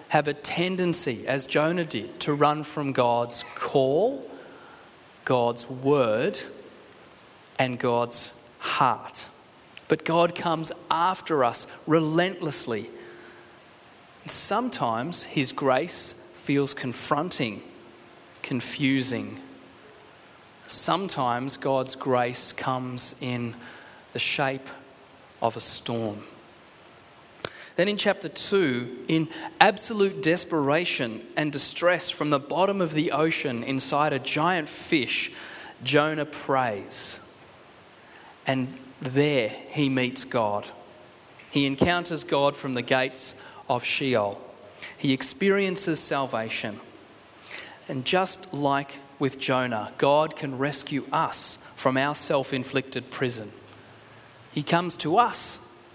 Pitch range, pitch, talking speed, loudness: 125-155 Hz, 135 Hz, 100 wpm, -25 LUFS